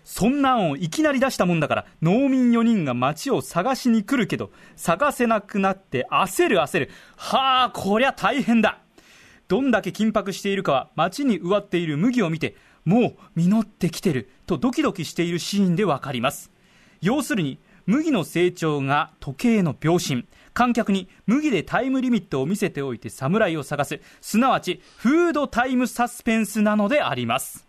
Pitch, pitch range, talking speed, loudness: 200 Hz, 165-240 Hz, 340 characters per minute, -22 LUFS